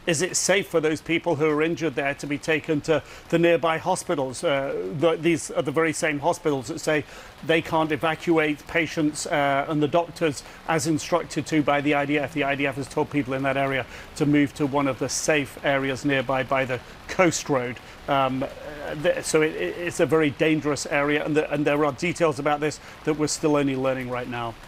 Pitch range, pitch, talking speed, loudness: 140-165 Hz, 150 Hz, 210 wpm, -24 LUFS